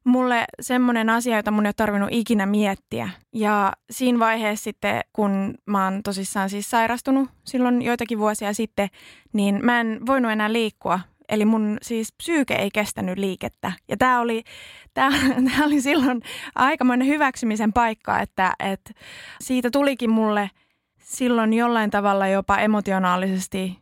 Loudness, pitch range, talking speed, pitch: -22 LUFS, 205-245 Hz, 140 wpm, 225 Hz